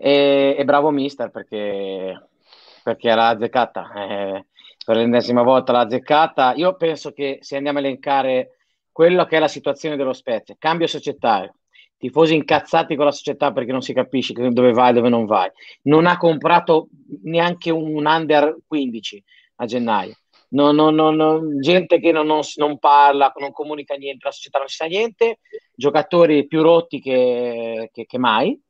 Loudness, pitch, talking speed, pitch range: -18 LUFS, 145 Hz, 165 wpm, 125-160 Hz